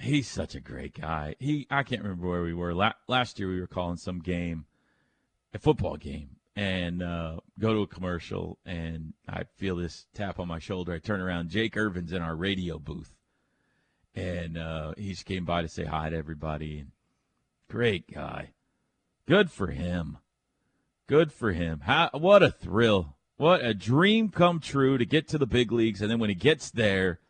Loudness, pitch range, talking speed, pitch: -28 LUFS, 85-115 Hz, 190 wpm, 95 Hz